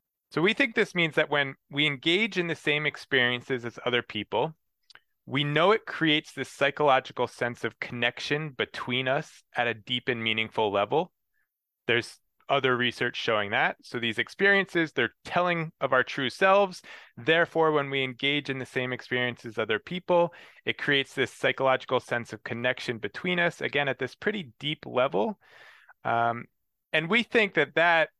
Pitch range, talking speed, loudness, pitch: 125-165 Hz, 170 wpm, -27 LUFS, 140 Hz